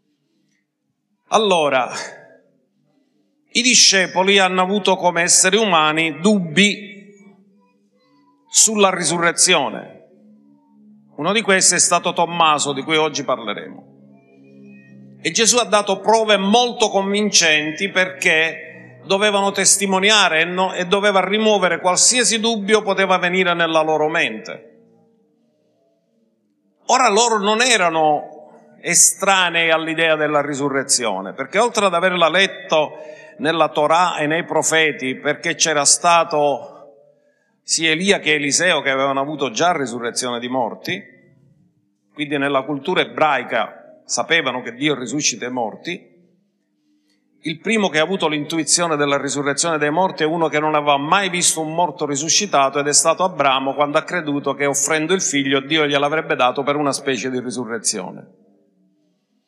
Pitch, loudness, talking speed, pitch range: 160 Hz, -16 LUFS, 125 wpm, 140-185 Hz